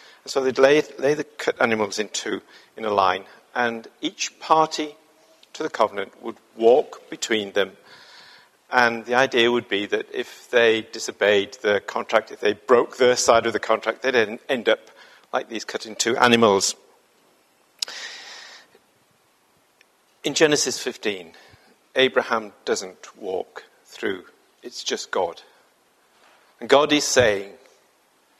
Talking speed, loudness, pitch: 135 wpm, -22 LUFS, 135 Hz